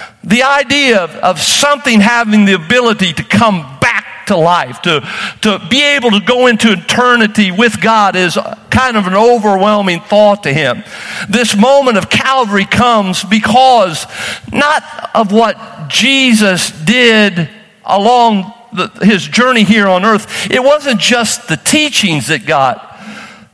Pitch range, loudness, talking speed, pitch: 195-245 Hz, -9 LUFS, 145 wpm, 220 Hz